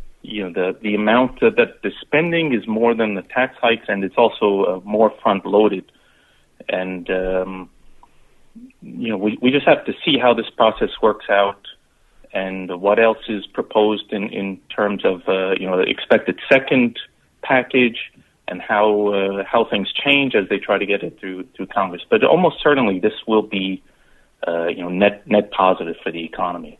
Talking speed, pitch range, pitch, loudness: 185 wpm, 95-120 Hz, 105 Hz, -18 LUFS